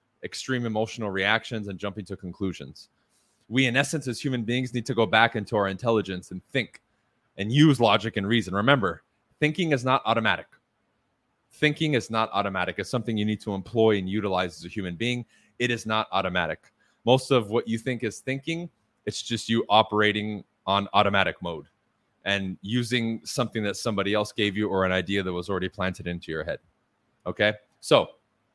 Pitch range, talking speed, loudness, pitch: 100-120 Hz, 180 wpm, -26 LUFS, 110 Hz